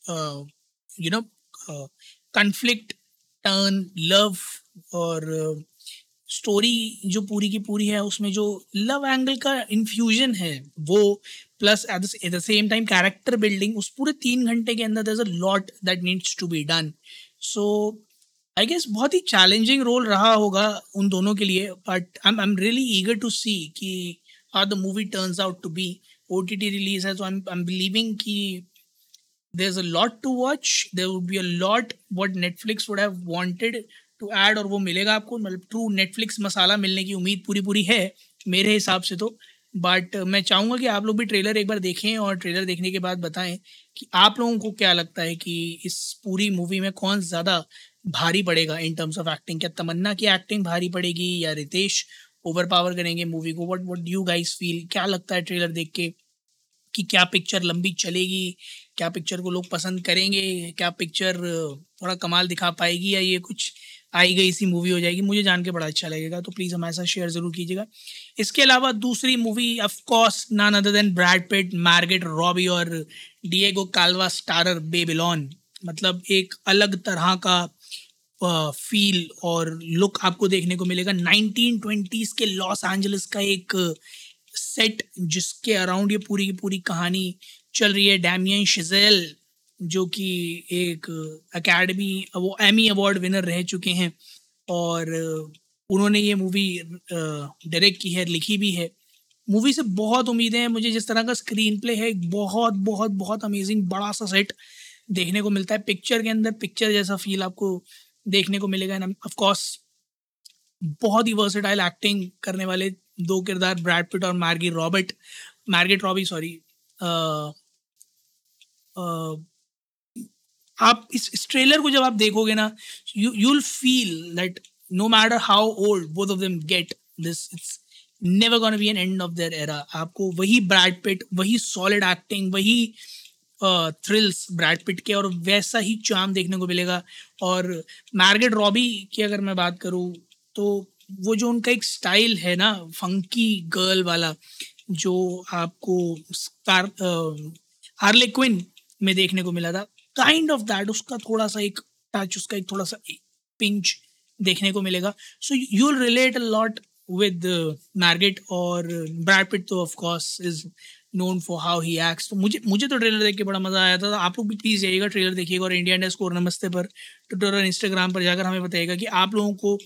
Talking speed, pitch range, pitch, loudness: 170 wpm, 180-210 Hz, 190 Hz, -22 LUFS